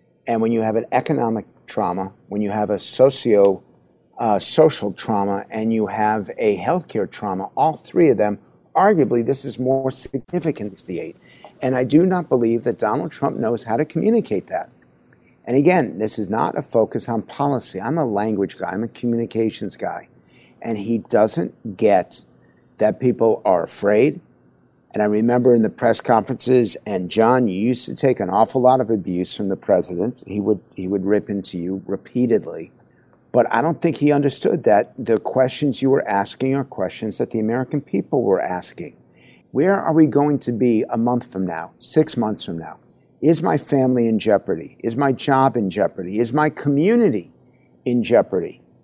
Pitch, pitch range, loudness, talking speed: 115 Hz, 105-130 Hz, -20 LUFS, 185 wpm